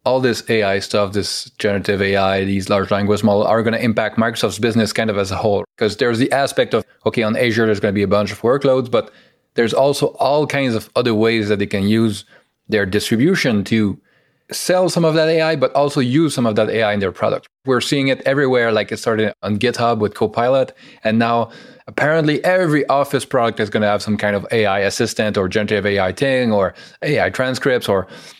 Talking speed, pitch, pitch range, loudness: 215 wpm, 110 Hz, 105-130 Hz, -17 LUFS